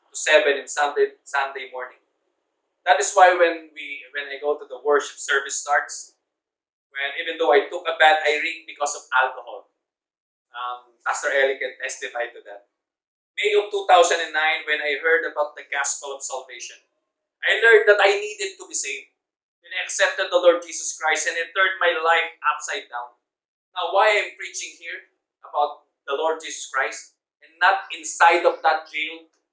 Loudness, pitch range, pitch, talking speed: -21 LUFS, 145-175 Hz, 160 Hz, 175 wpm